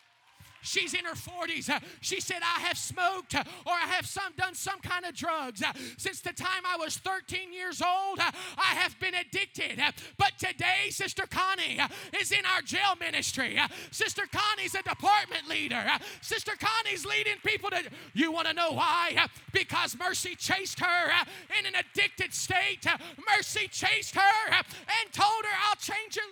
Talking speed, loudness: 160 wpm, -29 LUFS